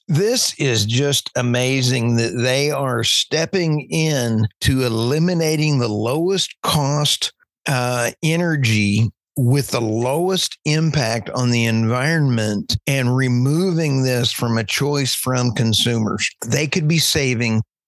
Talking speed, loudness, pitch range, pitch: 120 wpm, -18 LUFS, 115-150 Hz, 130 Hz